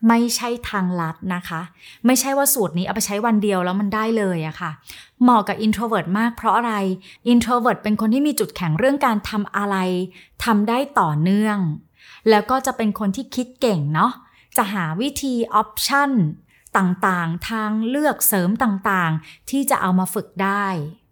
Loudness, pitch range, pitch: -20 LUFS, 185-235 Hz, 210 Hz